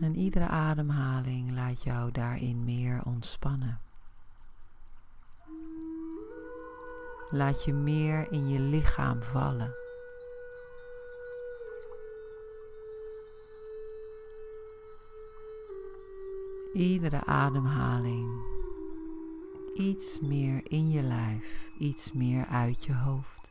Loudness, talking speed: -32 LUFS, 70 wpm